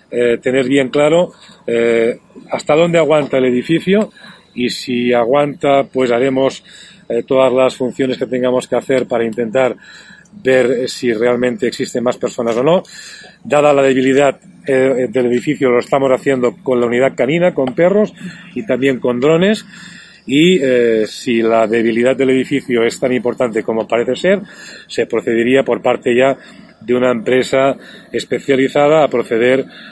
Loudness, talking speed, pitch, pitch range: -14 LUFS, 155 wpm, 130 Hz, 125-145 Hz